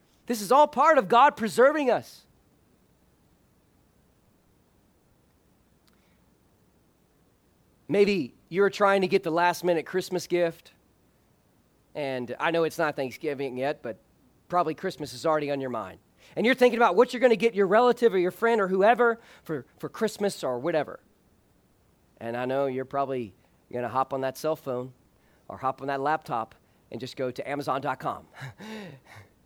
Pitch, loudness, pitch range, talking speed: 160 Hz, -26 LUFS, 130-200 Hz, 155 wpm